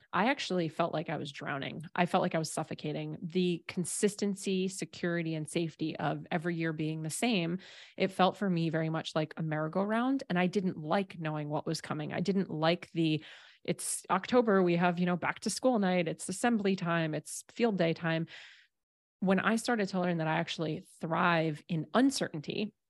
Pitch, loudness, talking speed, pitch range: 175 Hz, -32 LUFS, 190 wpm, 160-190 Hz